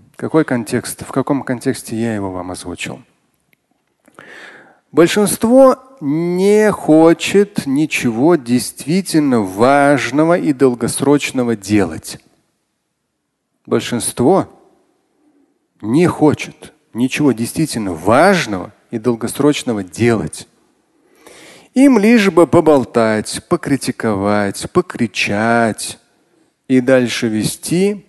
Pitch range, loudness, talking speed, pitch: 115-180 Hz, -14 LUFS, 75 wpm, 140 Hz